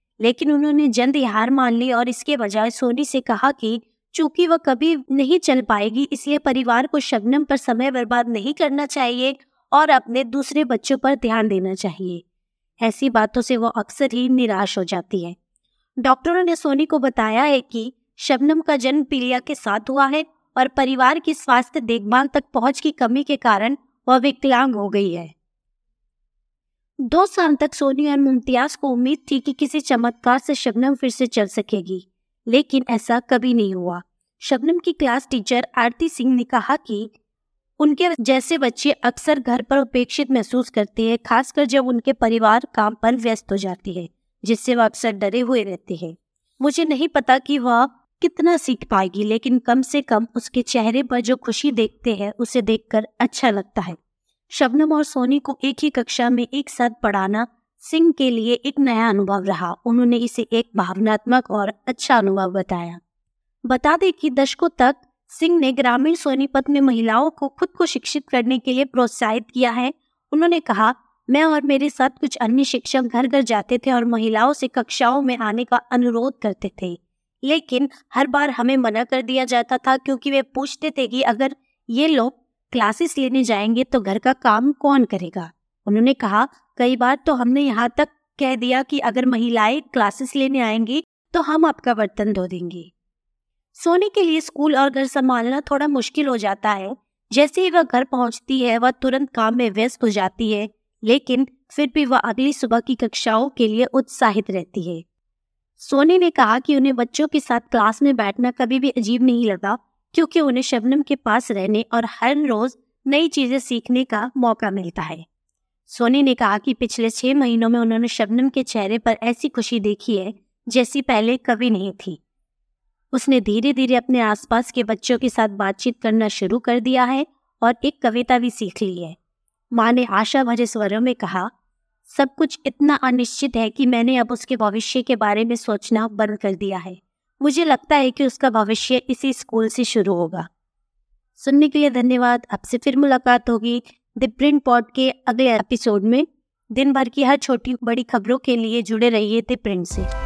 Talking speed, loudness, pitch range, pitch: 185 wpm, -19 LUFS, 225-275 Hz, 250 Hz